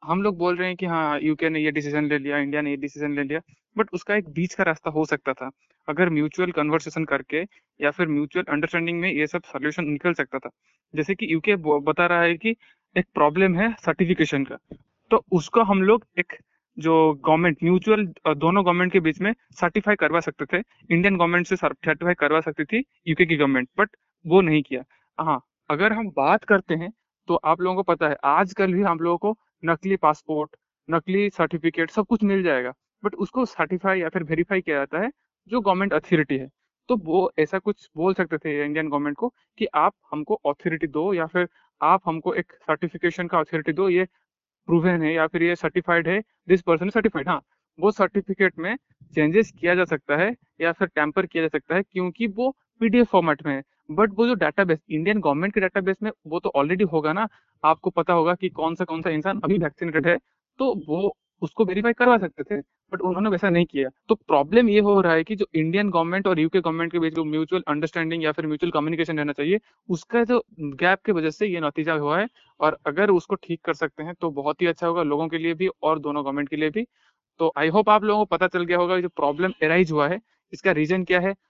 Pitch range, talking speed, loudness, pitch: 155-195 Hz, 220 wpm, -23 LUFS, 170 Hz